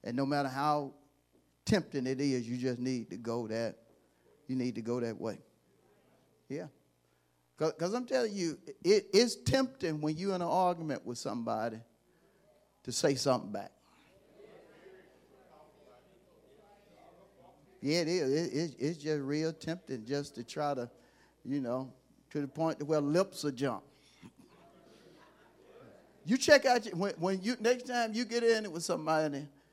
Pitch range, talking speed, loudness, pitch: 130-185 Hz, 155 wpm, -33 LUFS, 150 Hz